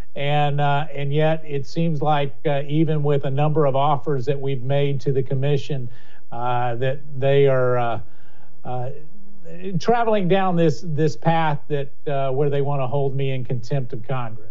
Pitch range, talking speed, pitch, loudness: 135-155 Hz, 180 wpm, 140 Hz, -22 LUFS